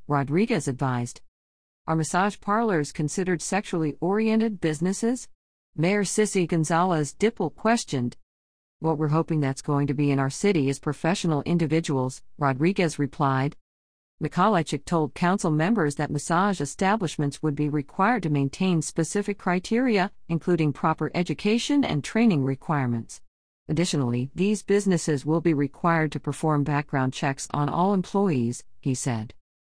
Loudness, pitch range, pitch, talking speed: -25 LUFS, 140-185 Hz, 155 Hz, 130 wpm